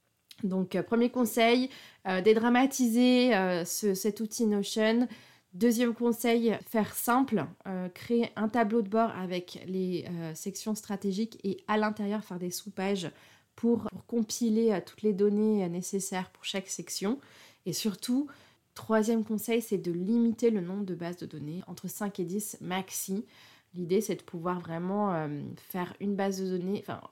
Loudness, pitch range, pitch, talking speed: -30 LUFS, 185-230 Hz, 205 Hz, 160 wpm